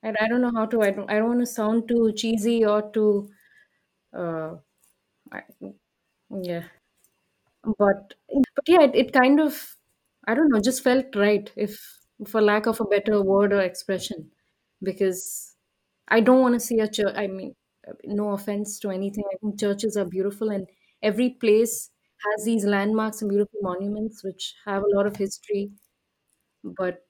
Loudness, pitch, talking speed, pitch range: -23 LUFS, 210 Hz, 170 wpm, 200-225 Hz